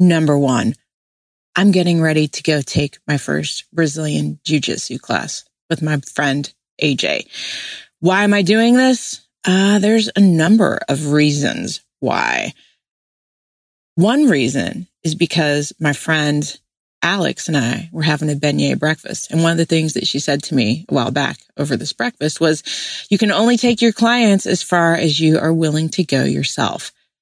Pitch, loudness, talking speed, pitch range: 160 Hz, -16 LUFS, 170 wpm, 145-190 Hz